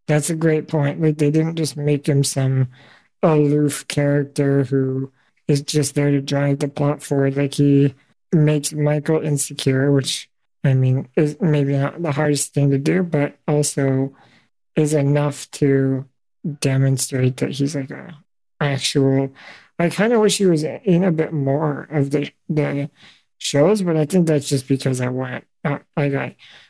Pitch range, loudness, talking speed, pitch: 140-155 Hz, -19 LUFS, 165 wpm, 145 Hz